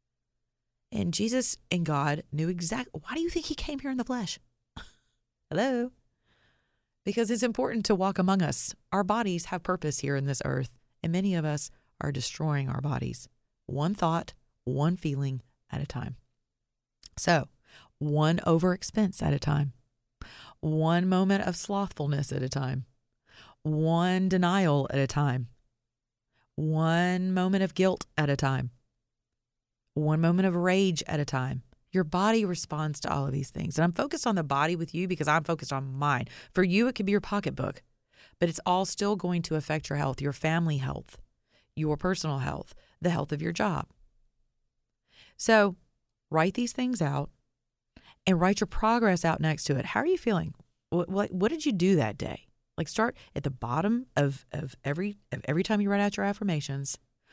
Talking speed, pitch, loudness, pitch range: 175 wpm, 160 Hz, -29 LUFS, 140-190 Hz